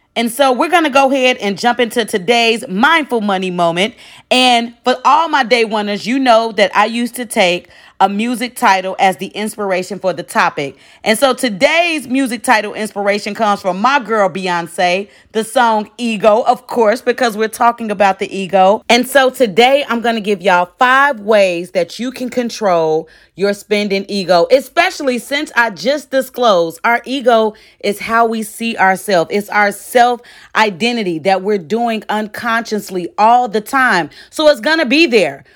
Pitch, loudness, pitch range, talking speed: 225 Hz, -14 LUFS, 200-250 Hz, 170 wpm